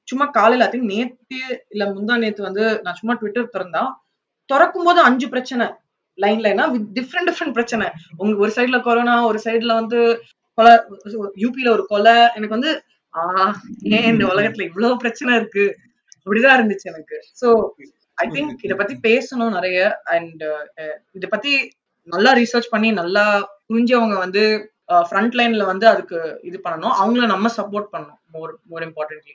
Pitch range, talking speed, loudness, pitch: 200-245 Hz, 145 wpm, -17 LUFS, 225 Hz